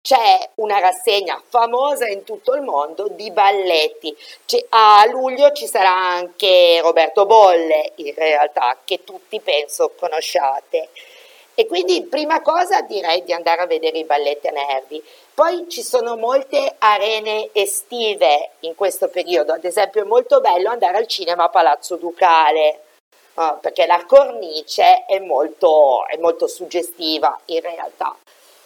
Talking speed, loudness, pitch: 140 wpm, -16 LUFS, 200 Hz